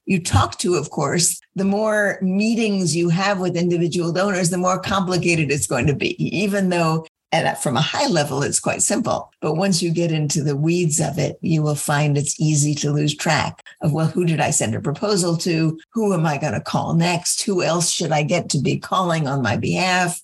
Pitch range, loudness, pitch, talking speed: 155-185 Hz, -20 LUFS, 170 Hz, 220 wpm